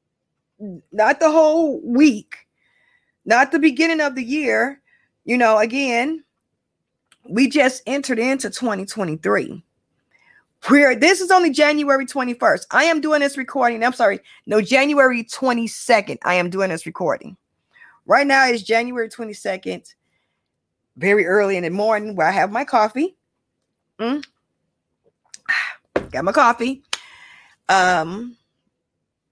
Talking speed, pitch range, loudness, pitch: 125 wpm, 210-285 Hz, -18 LUFS, 245 Hz